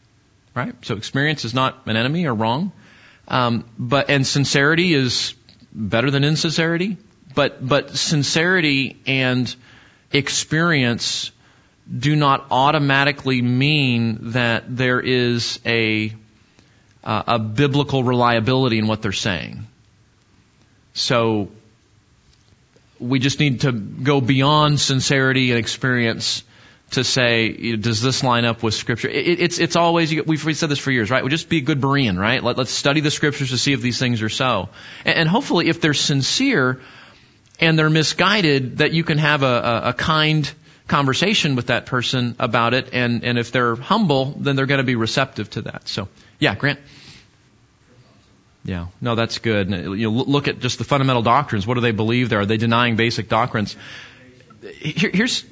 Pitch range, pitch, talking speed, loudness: 115-145 Hz, 130 Hz, 155 wpm, -19 LUFS